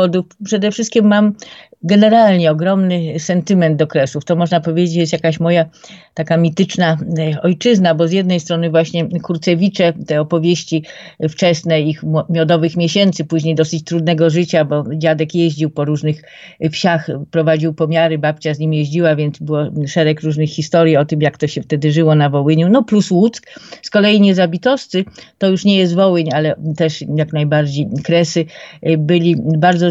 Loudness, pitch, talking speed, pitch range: -14 LUFS, 165 Hz, 155 wpm, 155-180 Hz